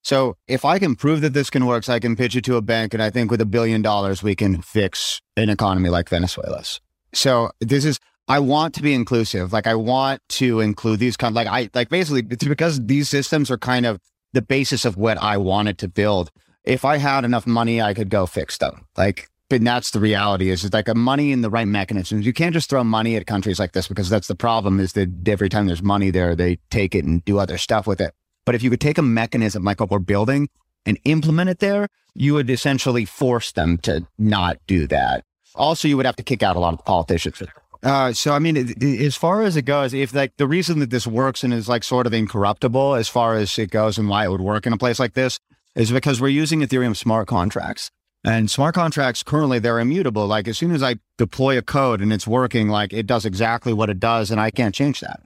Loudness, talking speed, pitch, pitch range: -20 LUFS, 250 wpm, 115 Hz, 105-135 Hz